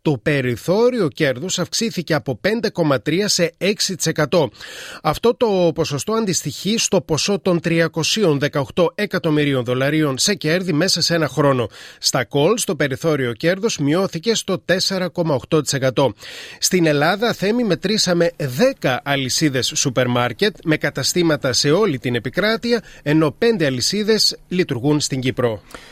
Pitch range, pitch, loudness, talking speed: 145-195 Hz, 165 Hz, -18 LUFS, 120 wpm